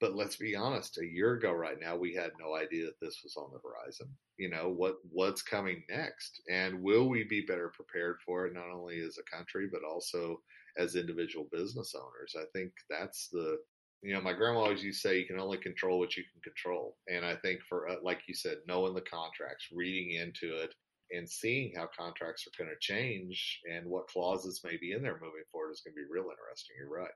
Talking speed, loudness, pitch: 230 wpm, -37 LUFS, 95 Hz